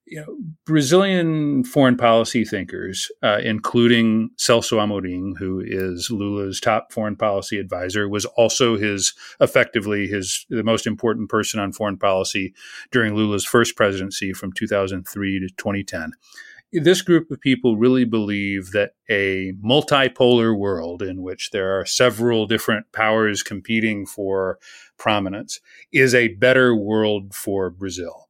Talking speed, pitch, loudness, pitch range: 135 wpm, 110 Hz, -20 LUFS, 95-120 Hz